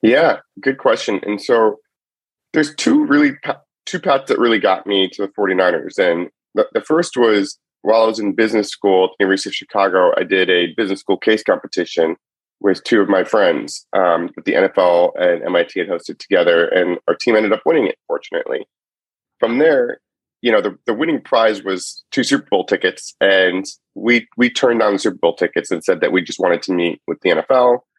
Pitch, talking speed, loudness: 155 Hz, 205 wpm, -16 LUFS